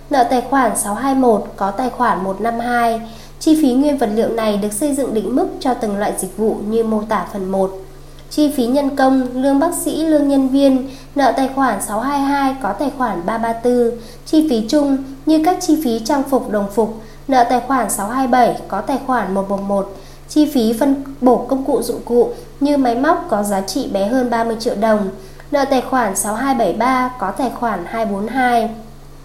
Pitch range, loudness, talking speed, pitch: 215-275 Hz, -17 LUFS, 190 wpm, 245 Hz